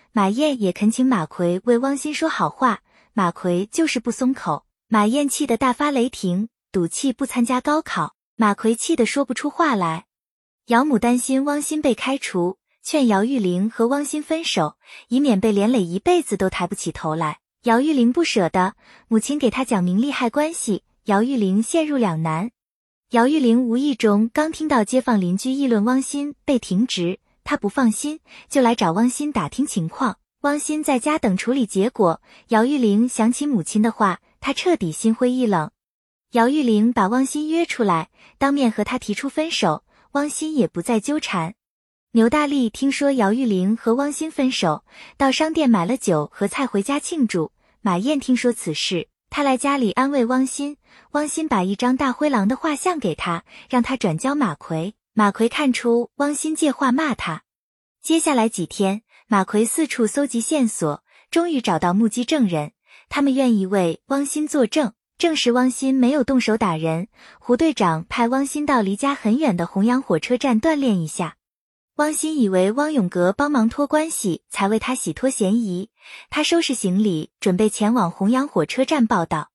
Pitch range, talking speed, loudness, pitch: 205-280 Hz, 260 characters per minute, -20 LUFS, 240 Hz